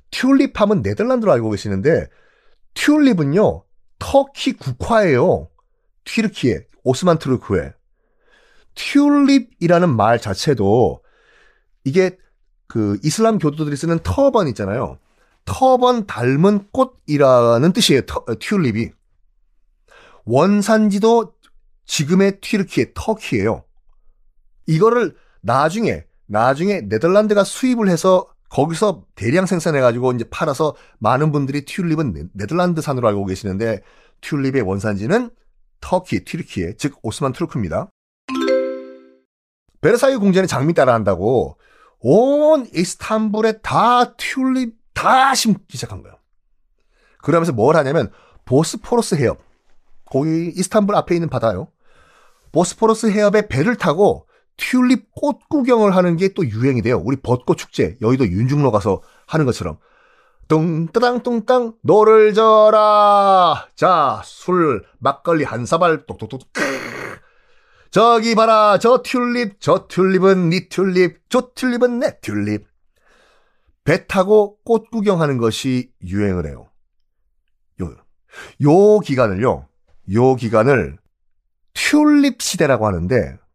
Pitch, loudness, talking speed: 170 Hz, -16 LUFS, 255 characters per minute